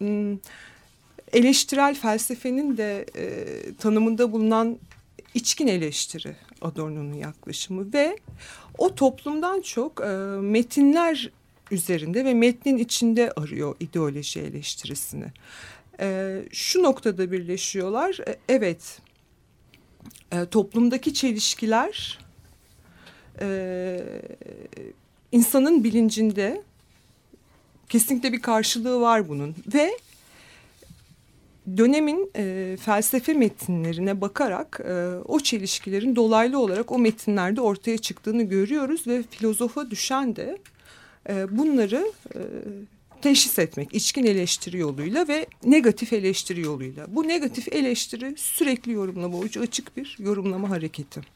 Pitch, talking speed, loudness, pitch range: 225 Hz, 95 wpm, -24 LUFS, 190-265 Hz